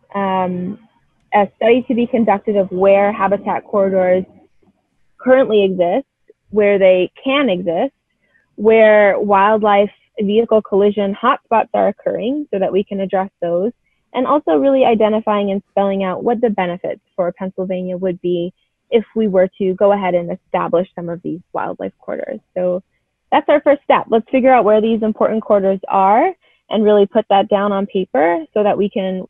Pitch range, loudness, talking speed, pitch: 190-225 Hz, -16 LUFS, 165 wpm, 200 Hz